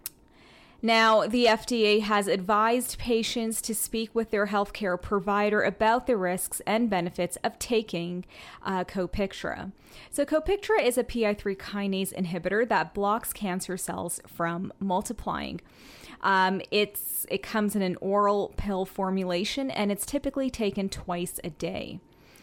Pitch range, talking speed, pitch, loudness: 185-225 Hz, 135 wpm, 205 Hz, -27 LUFS